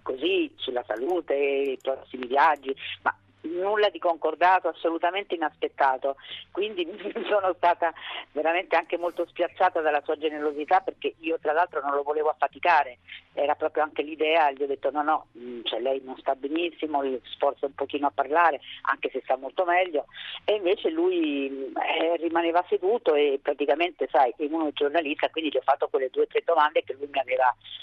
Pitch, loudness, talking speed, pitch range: 165 Hz, -26 LUFS, 175 wpm, 140-205 Hz